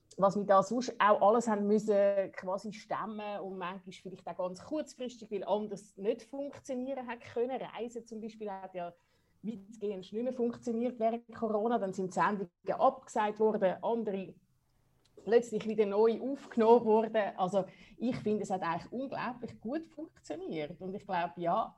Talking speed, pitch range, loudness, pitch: 160 wpm, 195-235 Hz, -33 LUFS, 215 Hz